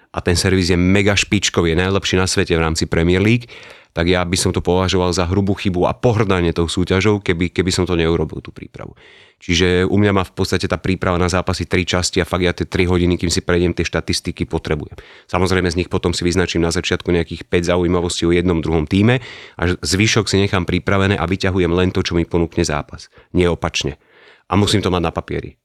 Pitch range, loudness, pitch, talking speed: 85-95 Hz, -17 LUFS, 90 Hz, 220 wpm